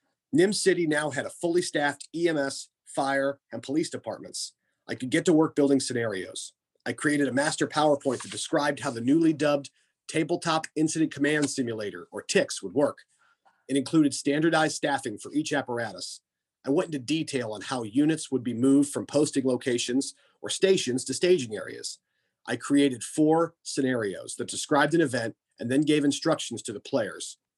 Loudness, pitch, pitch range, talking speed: -27 LUFS, 145 Hz, 130-155 Hz, 170 wpm